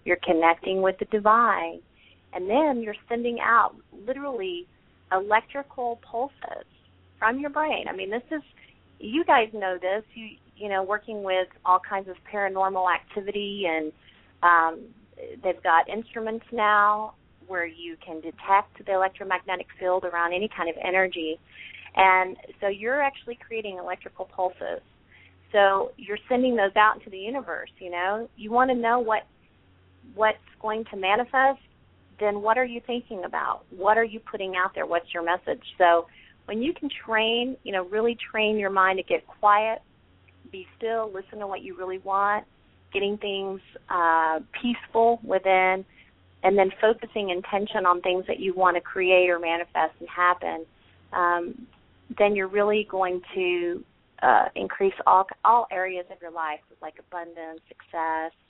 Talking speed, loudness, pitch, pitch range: 155 wpm, -25 LUFS, 195 Hz, 175-225 Hz